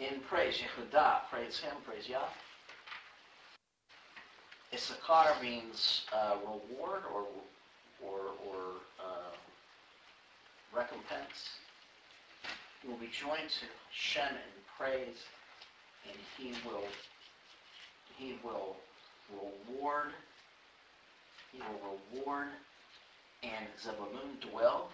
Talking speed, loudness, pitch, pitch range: 85 wpm, -38 LUFS, 120 Hz, 100-135 Hz